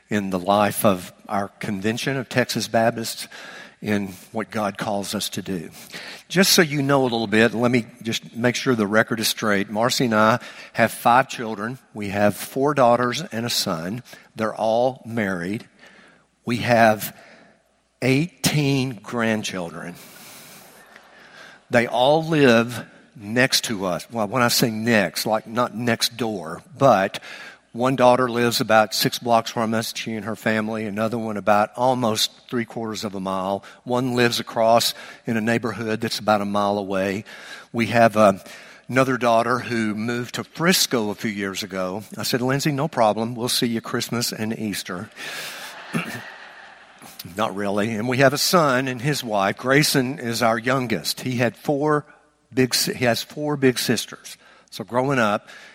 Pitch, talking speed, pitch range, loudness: 115 Hz, 160 wpm, 105-125 Hz, -21 LUFS